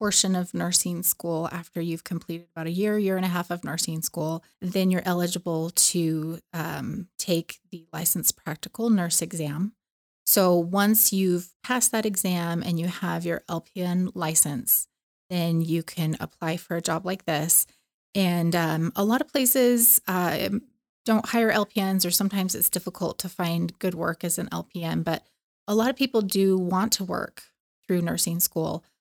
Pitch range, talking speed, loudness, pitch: 170-200 Hz, 170 wpm, -24 LUFS, 180 Hz